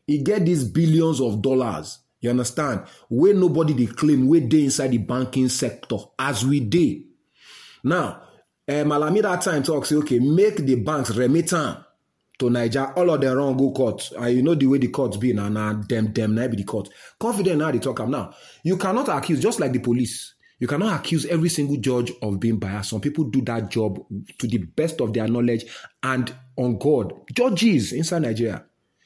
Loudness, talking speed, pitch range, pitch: -22 LUFS, 190 wpm, 120-155 Hz, 135 Hz